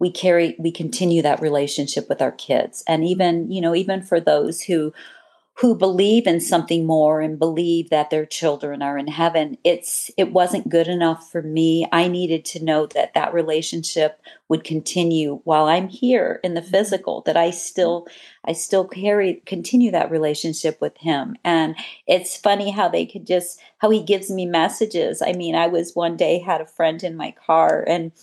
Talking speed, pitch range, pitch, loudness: 185 wpm, 160-180 Hz, 170 Hz, -20 LUFS